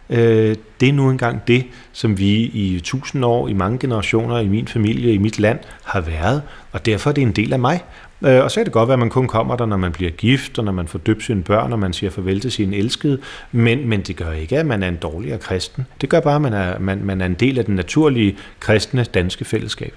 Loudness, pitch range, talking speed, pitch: -18 LUFS, 100-125 Hz, 260 wpm, 110 Hz